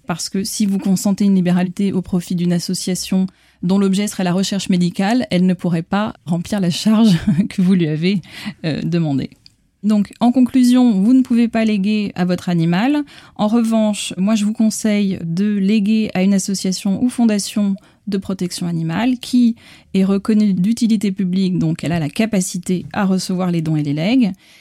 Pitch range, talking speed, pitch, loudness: 180-215 Hz, 180 wpm, 195 Hz, -17 LUFS